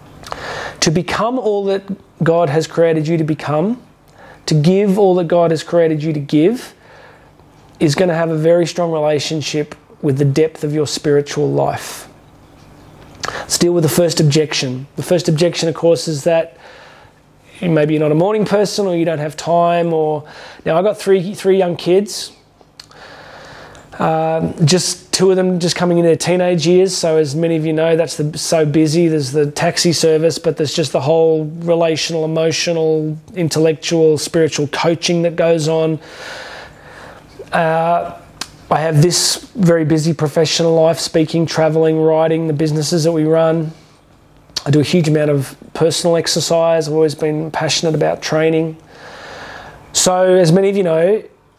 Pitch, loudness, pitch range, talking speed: 165 Hz, -15 LUFS, 155-175 Hz, 165 wpm